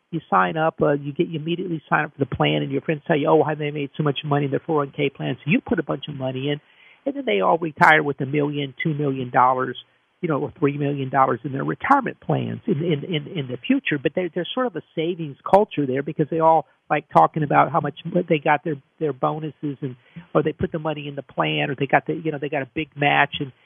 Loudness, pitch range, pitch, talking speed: -22 LUFS, 140-165 Hz, 150 Hz, 280 wpm